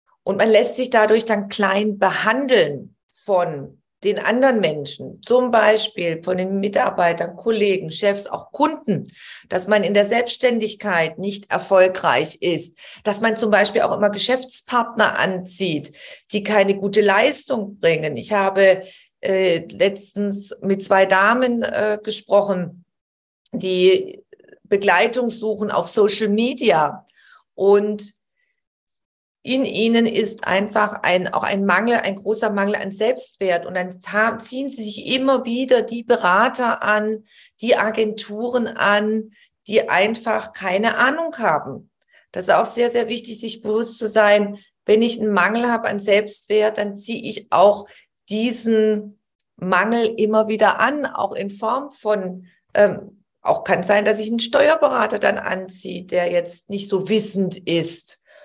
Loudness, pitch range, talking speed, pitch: -19 LUFS, 195-230 Hz, 140 wpm, 210 Hz